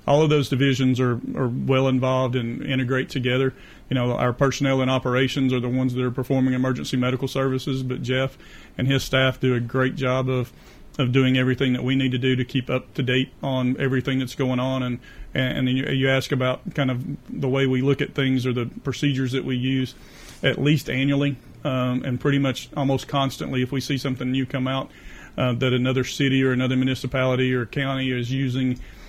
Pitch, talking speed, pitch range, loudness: 130 Hz, 210 wpm, 130-135 Hz, -23 LUFS